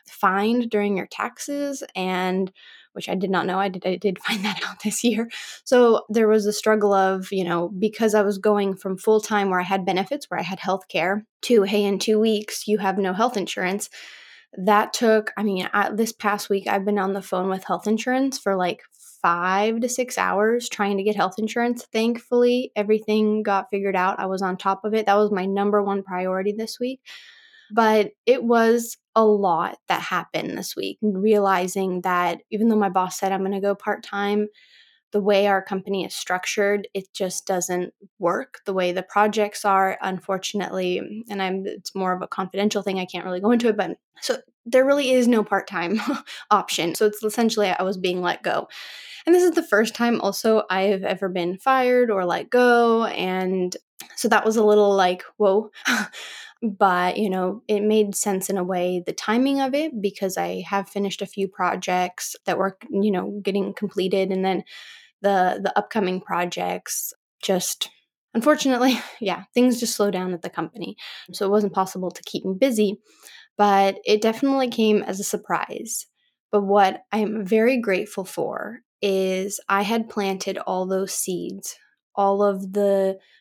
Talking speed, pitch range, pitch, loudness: 190 wpm, 190-220 Hz, 205 Hz, -22 LUFS